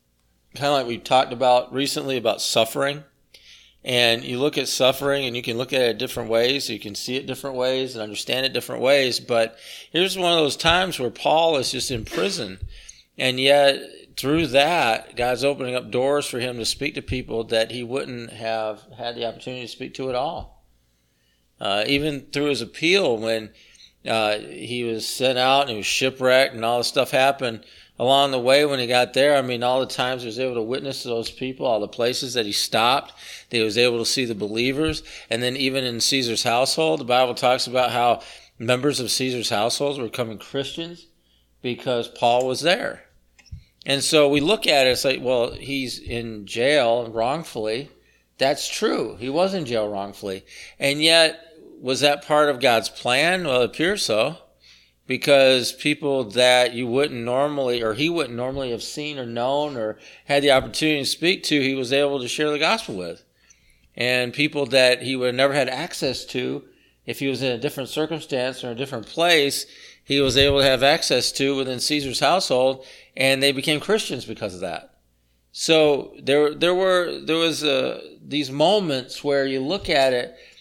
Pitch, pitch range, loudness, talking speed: 130 Hz, 115-140 Hz, -21 LUFS, 195 wpm